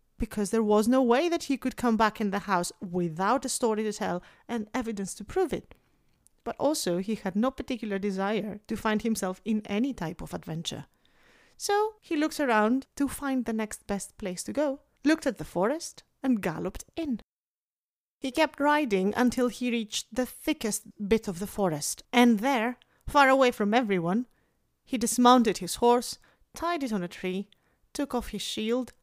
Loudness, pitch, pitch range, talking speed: -28 LUFS, 230 Hz, 205-265 Hz, 180 wpm